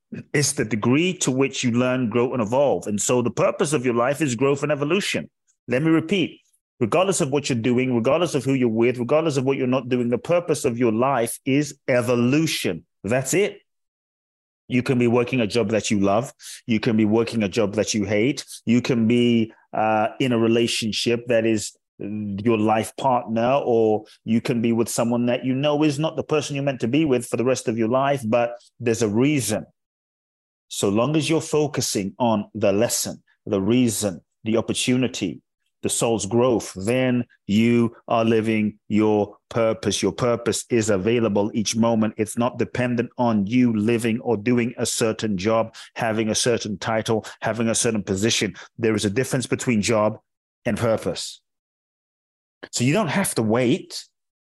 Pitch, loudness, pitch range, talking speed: 120 Hz, -22 LUFS, 110-130 Hz, 185 wpm